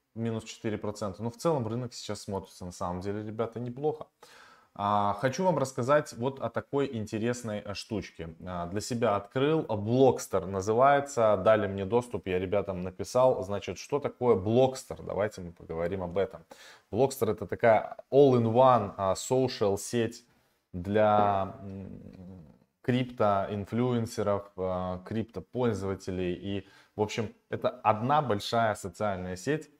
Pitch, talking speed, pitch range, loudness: 105 Hz, 135 wpm, 95-125 Hz, -29 LUFS